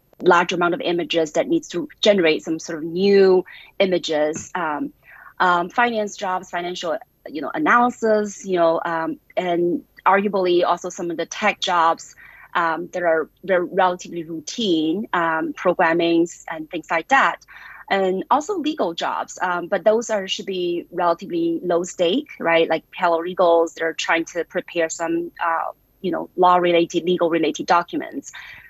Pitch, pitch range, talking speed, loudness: 175 Hz, 165-190 Hz, 155 wpm, -20 LUFS